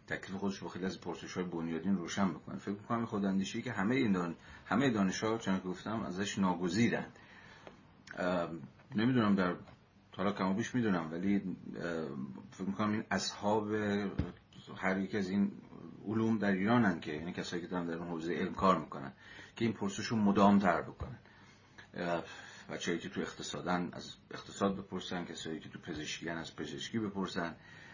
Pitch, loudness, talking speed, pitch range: 100 Hz, -35 LUFS, 155 wpm, 90-105 Hz